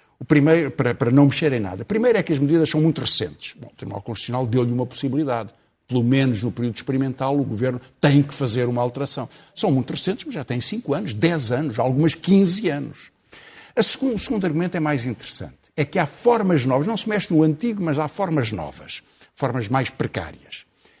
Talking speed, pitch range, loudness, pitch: 210 wpm, 125-165 Hz, -21 LUFS, 140 Hz